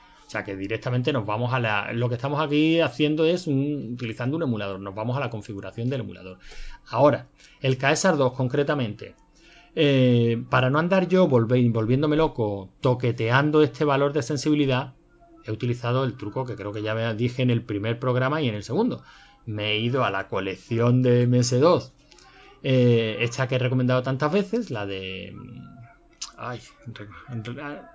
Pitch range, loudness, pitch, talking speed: 115-140 Hz, -24 LUFS, 125 Hz, 170 wpm